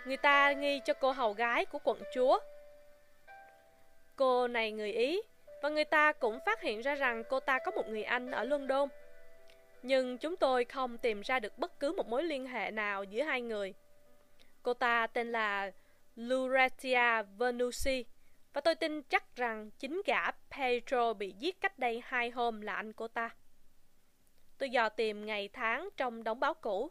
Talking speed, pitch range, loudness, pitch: 180 wpm, 215-285 Hz, -33 LUFS, 245 Hz